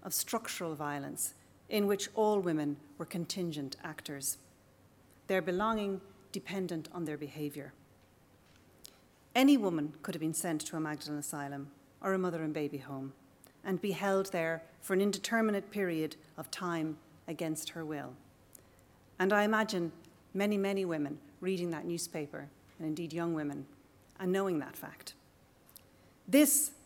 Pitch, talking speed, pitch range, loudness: 165 Hz, 140 wpm, 145-190 Hz, -35 LUFS